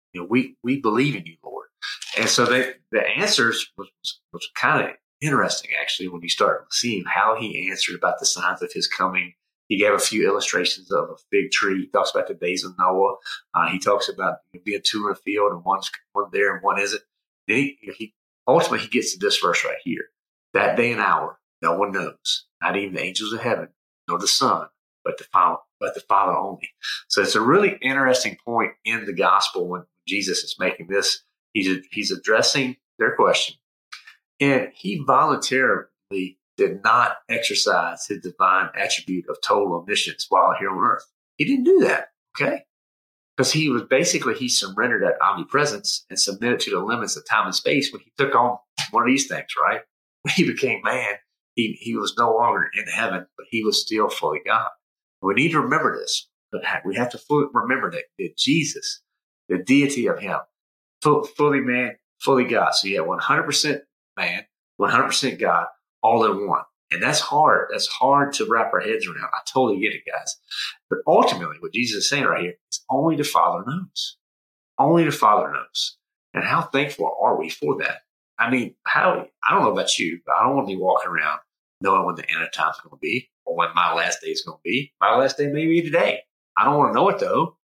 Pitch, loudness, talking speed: 180 Hz, -21 LUFS, 210 wpm